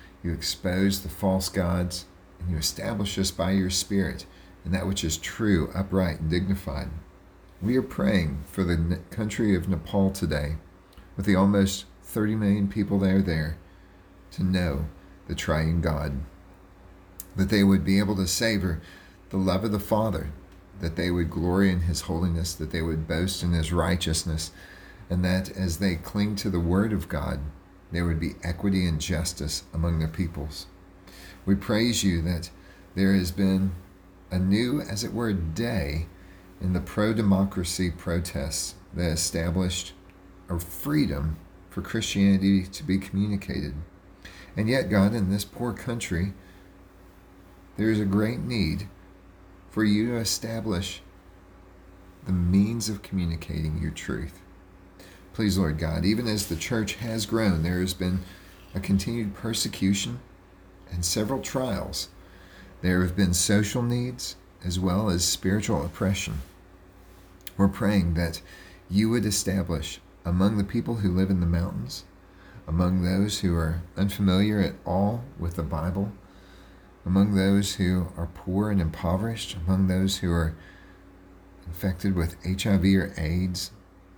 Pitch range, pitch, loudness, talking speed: 90-95 Hz, 95 Hz, -26 LUFS, 145 wpm